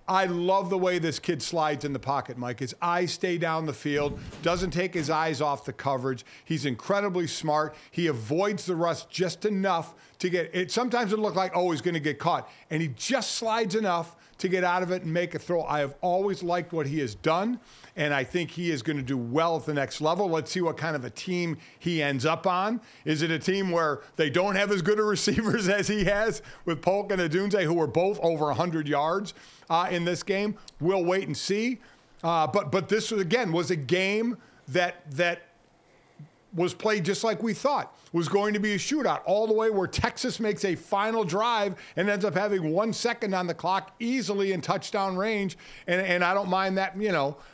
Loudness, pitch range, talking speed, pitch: -27 LUFS, 160-200 Hz, 225 wpm, 180 Hz